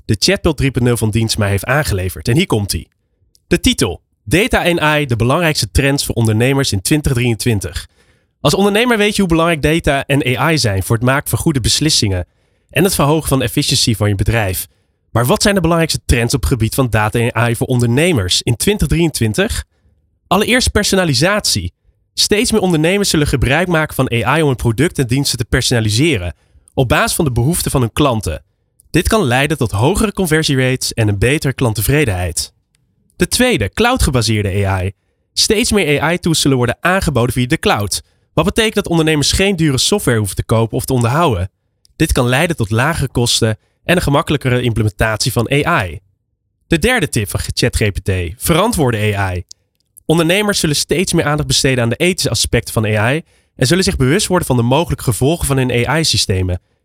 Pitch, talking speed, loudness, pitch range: 130 Hz, 175 wpm, -14 LUFS, 110-160 Hz